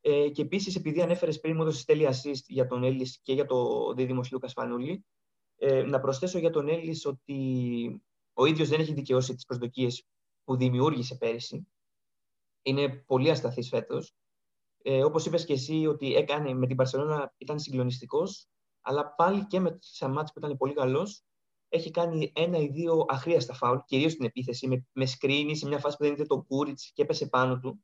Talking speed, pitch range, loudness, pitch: 185 wpm, 130-155 Hz, -29 LUFS, 140 Hz